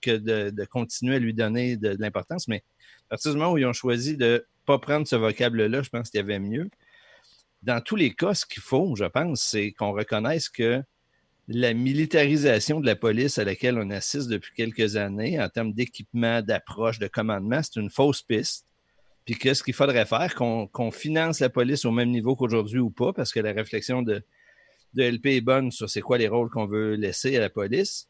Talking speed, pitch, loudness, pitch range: 220 wpm, 120 Hz, -25 LUFS, 110-130 Hz